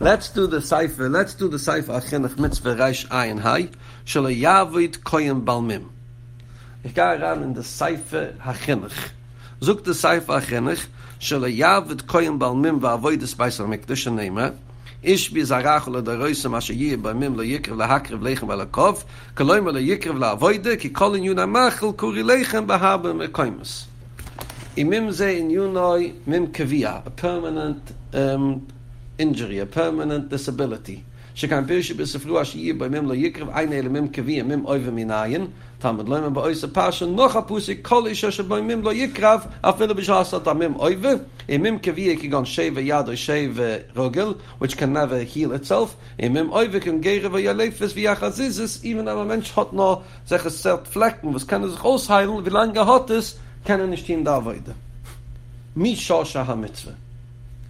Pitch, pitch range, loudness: 145 Hz, 120-185 Hz, -21 LUFS